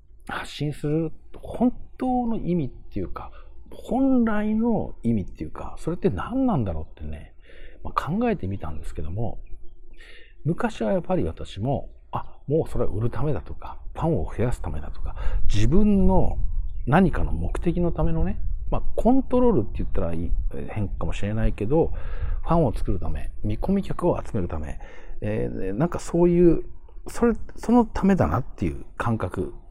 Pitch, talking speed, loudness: 115 Hz, 325 characters per minute, -26 LUFS